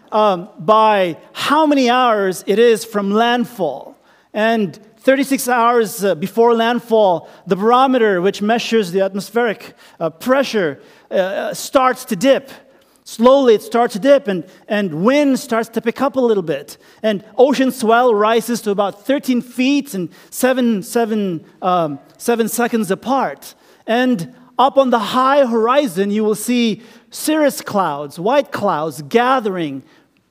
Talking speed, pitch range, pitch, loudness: 140 wpm, 200-250 Hz, 230 Hz, -16 LUFS